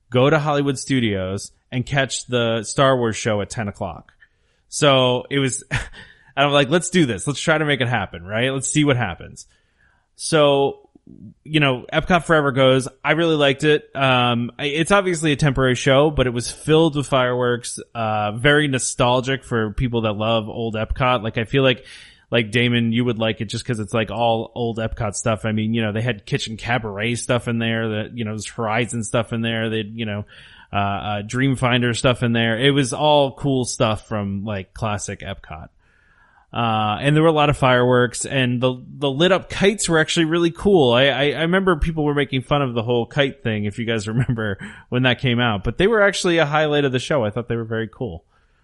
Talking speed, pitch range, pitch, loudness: 215 wpm, 115-140 Hz, 125 Hz, -19 LUFS